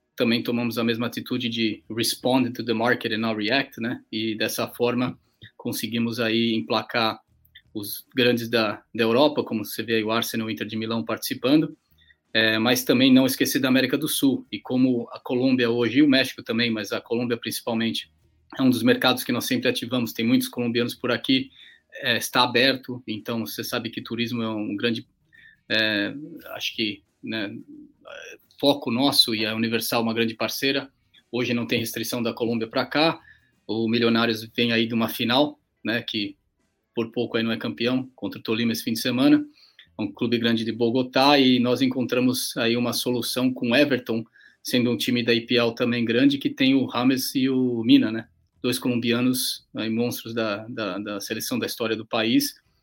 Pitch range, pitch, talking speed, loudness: 115-130 Hz, 120 Hz, 190 wpm, -23 LUFS